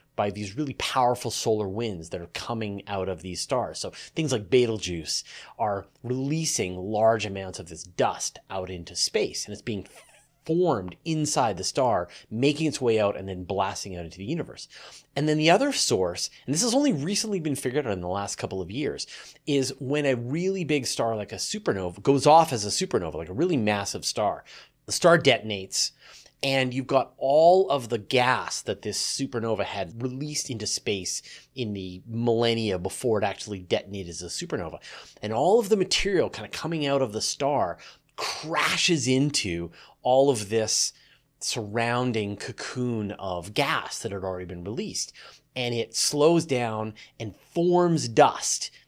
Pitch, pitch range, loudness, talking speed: 120 Hz, 100-145 Hz, -26 LUFS, 175 wpm